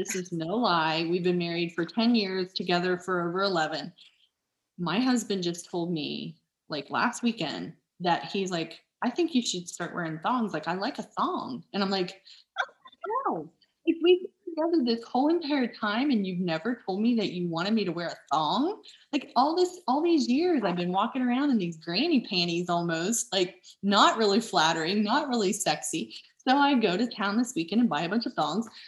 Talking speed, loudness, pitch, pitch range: 205 wpm, -28 LUFS, 215 Hz, 180-255 Hz